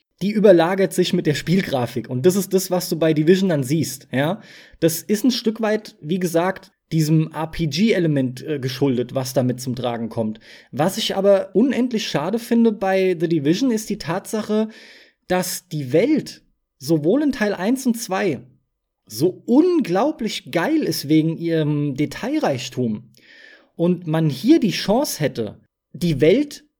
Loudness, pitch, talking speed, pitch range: -20 LUFS, 180 Hz, 150 wpm, 150-210 Hz